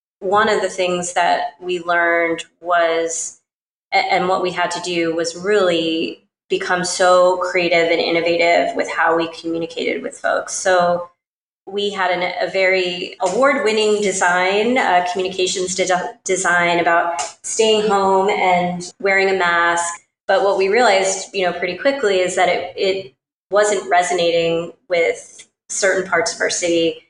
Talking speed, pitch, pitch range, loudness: 145 wpm, 180 Hz, 170-195 Hz, -17 LUFS